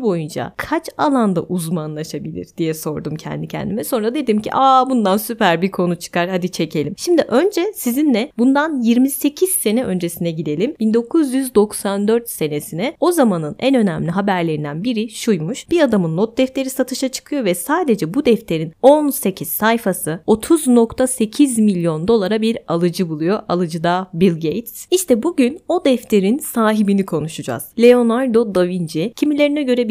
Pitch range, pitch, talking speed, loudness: 175-260 Hz, 220 Hz, 140 wpm, -17 LUFS